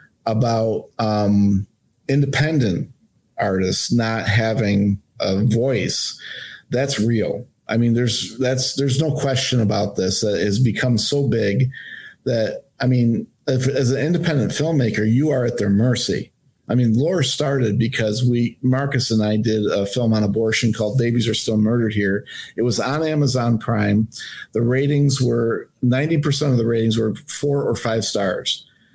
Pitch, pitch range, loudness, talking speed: 120 Hz, 110-130 Hz, -19 LUFS, 155 wpm